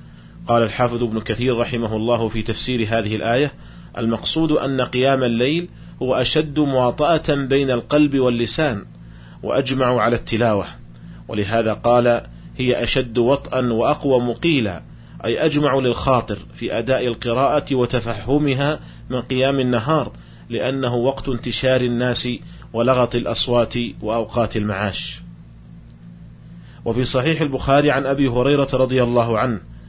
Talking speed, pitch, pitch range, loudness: 115 wpm, 125 Hz, 115-135 Hz, -19 LUFS